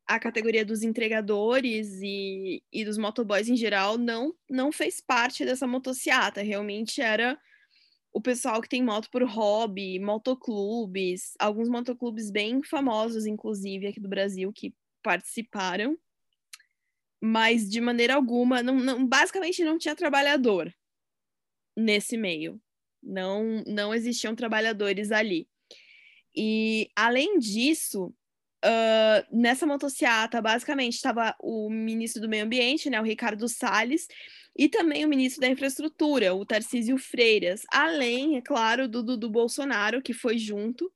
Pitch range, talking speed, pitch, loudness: 215-270 Hz, 130 wpm, 235 Hz, -26 LUFS